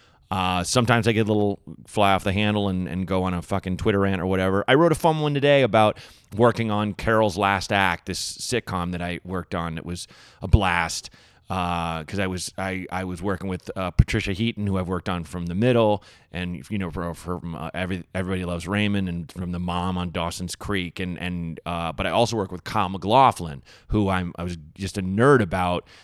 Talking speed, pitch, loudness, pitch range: 220 wpm, 95 Hz, -24 LUFS, 90-105 Hz